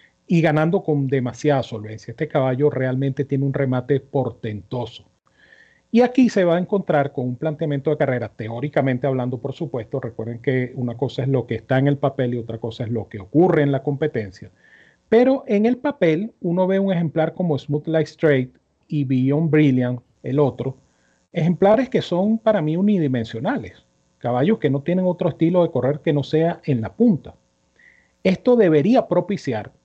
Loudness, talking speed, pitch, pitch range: -20 LUFS, 175 wpm, 145 Hz, 125-170 Hz